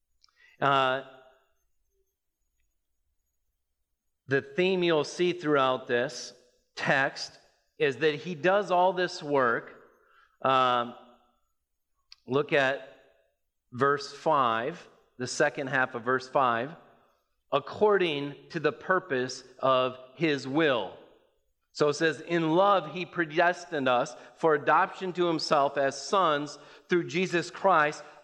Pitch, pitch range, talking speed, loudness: 145 Hz, 130-175 Hz, 105 wpm, -27 LUFS